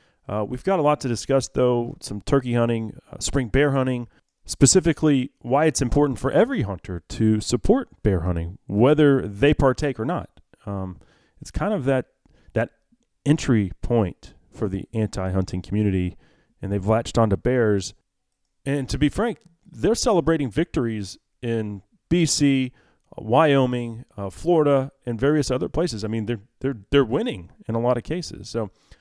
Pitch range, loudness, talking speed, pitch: 105-140 Hz, -22 LUFS, 155 wpm, 125 Hz